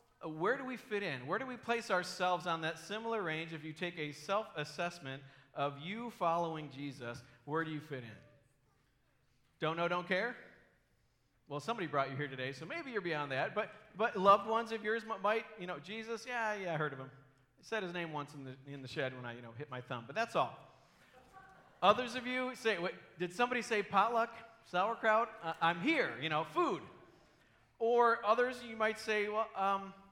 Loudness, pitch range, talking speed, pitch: -36 LUFS, 145-225 Hz, 205 wpm, 180 Hz